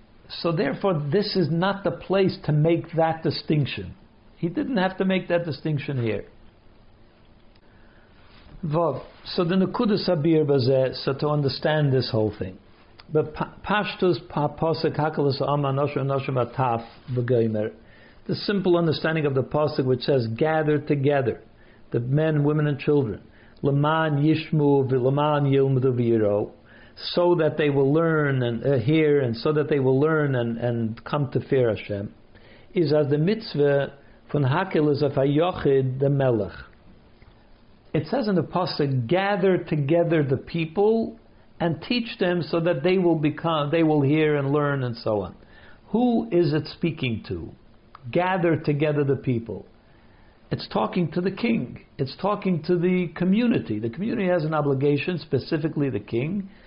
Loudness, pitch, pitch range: -23 LUFS, 145 Hz, 125-170 Hz